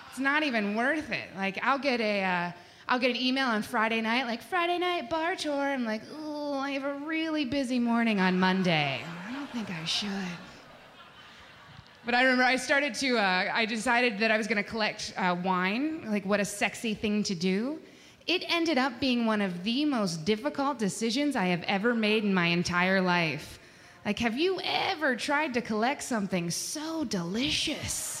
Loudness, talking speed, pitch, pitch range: -28 LUFS, 190 wpm, 230 Hz, 195-280 Hz